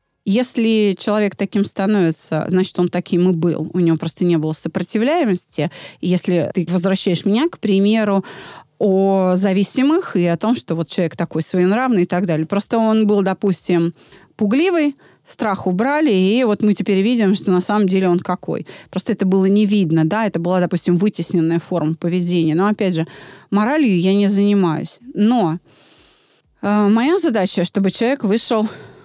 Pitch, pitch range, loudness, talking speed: 195 Hz, 175-210 Hz, -17 LUFS, 160 wpm